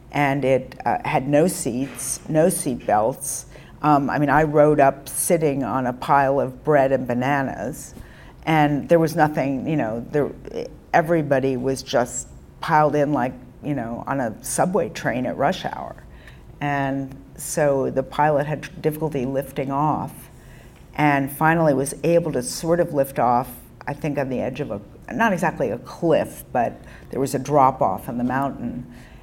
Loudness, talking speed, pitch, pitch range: -21 LUFS, 170 wpm, 140 Hz, 130-150 Hz